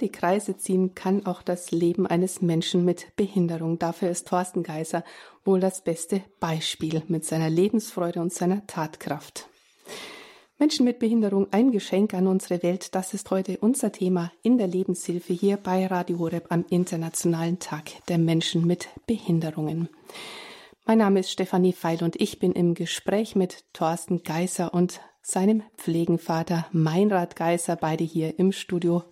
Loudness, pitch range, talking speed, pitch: -25 LUFS, 170-190 Hz, 155 wpm, 180 Hz